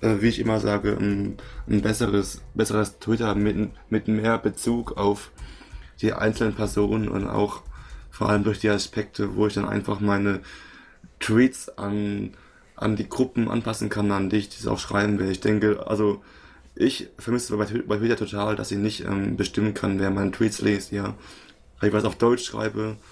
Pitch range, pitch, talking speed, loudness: 100-110 Hz, 105 Hz, 170 wpm, -25 LUFS